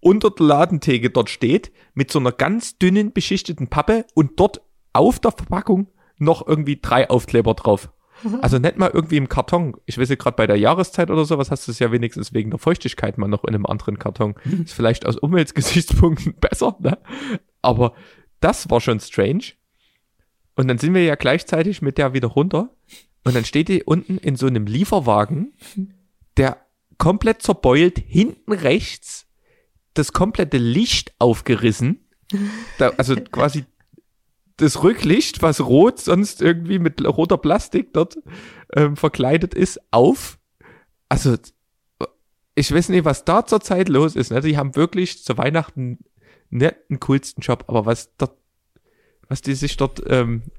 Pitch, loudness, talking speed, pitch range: 155 Hz, -19 LUFS, 160 wpm, 125-185 Hz